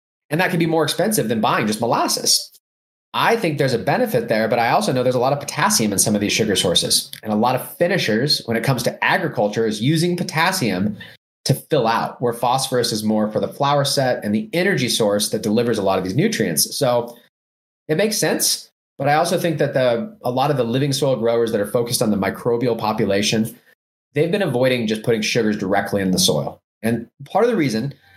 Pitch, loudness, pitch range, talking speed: 120 Hz, -19 LUFS, 105-145 Hz, 225 wpm